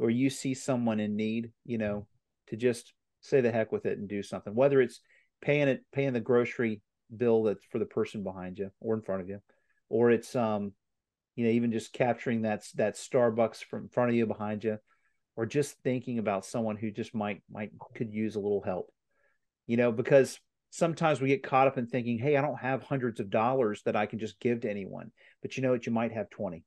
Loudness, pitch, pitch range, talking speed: -30 LUFS, 115 Hz, 105-130 Hz, 225 wpm